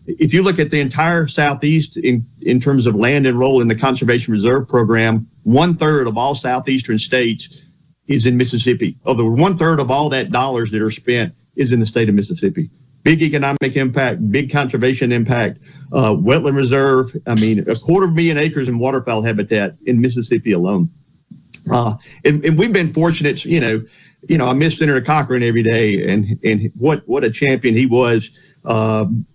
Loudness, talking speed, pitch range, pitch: -16 LUFS, 185 wpm, 115-155 Hz, 130 Hz